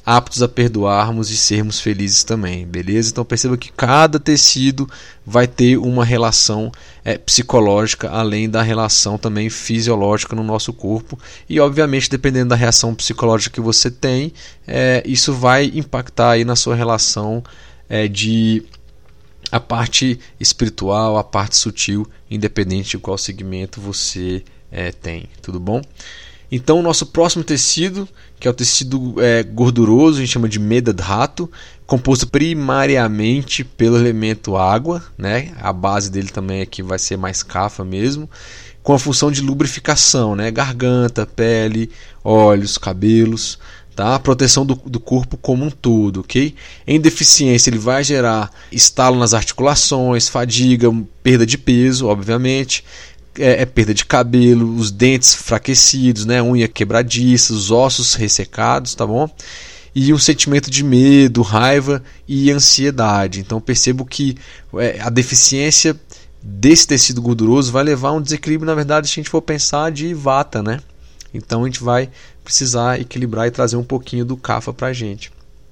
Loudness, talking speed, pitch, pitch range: -14 LUFS, 145 wpm, 120 Hz, 110-135 Hz